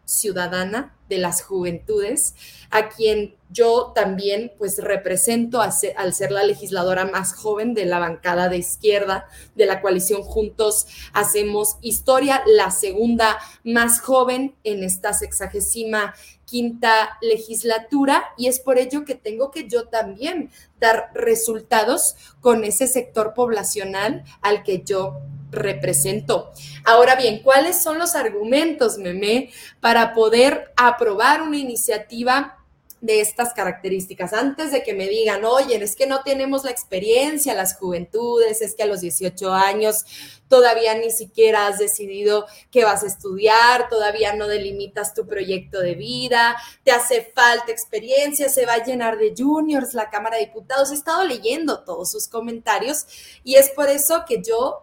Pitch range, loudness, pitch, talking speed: 205-255 Hz, -19 LUFS, 225 Hz, 145 wpm